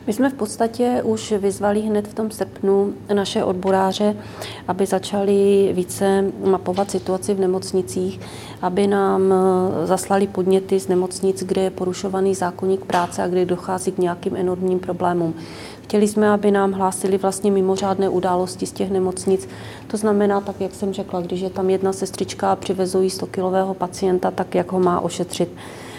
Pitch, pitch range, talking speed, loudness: 190 Hz, 185-200 Hz, 155 wpm, -20 LUFS